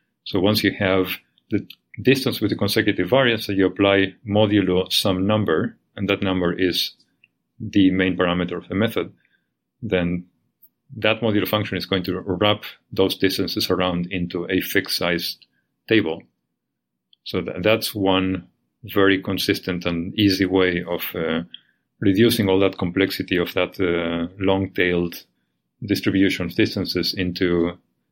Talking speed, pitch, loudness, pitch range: 145 wpm, 95 Hz, -21 LUFS, 90-100 Hz